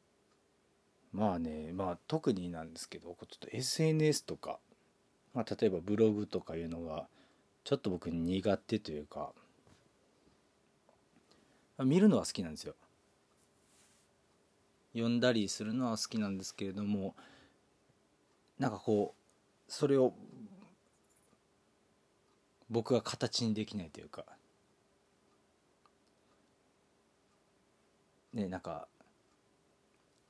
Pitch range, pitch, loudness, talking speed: 90-125 Hz, 105 Hz, -35 LUFS, 200 characters per minute